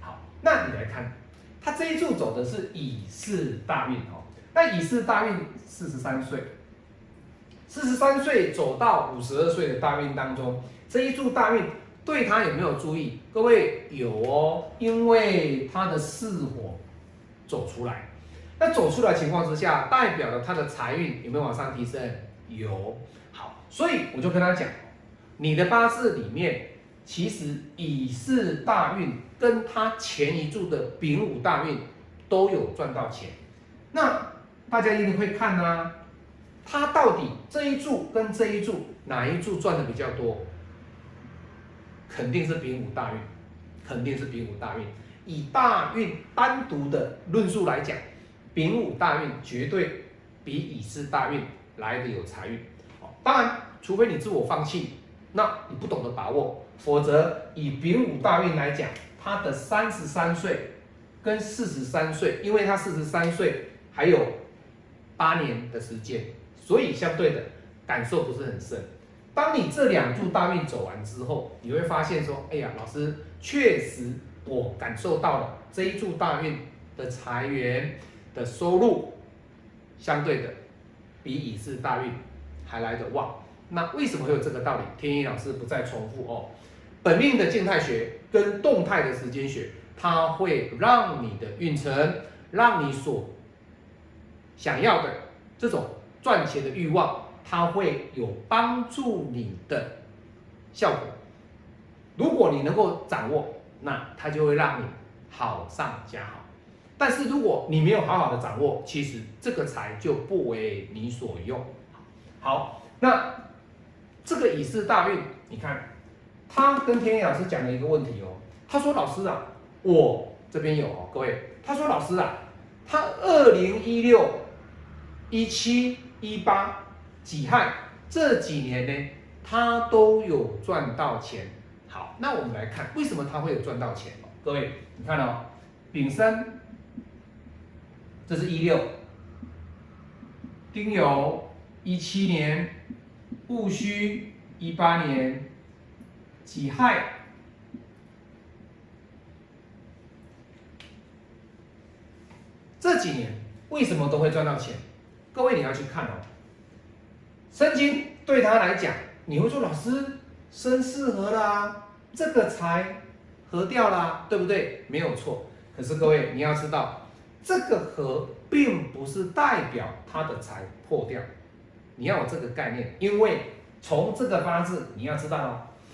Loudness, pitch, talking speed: -26 LUFS, 150 Hz, 200 characters per minute